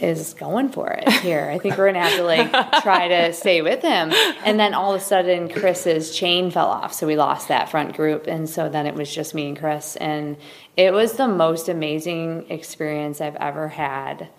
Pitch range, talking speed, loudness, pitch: 155-190 Hz, 215 wpm, -20 LUFS, 165 Hz